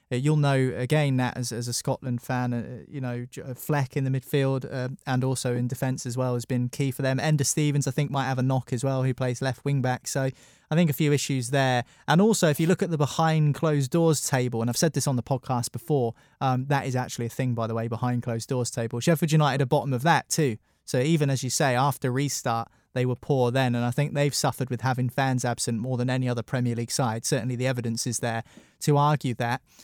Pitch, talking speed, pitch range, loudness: 130 Hz, 250 wpm, 125-145 Hz, -26 LUFS